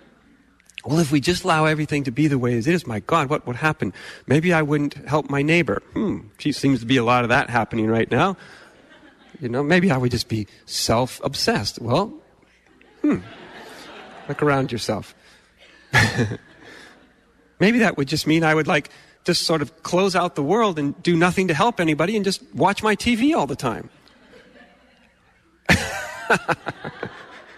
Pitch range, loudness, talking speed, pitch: 135-180 Hz, -21 LUFS, 170 wpm, 155 Hz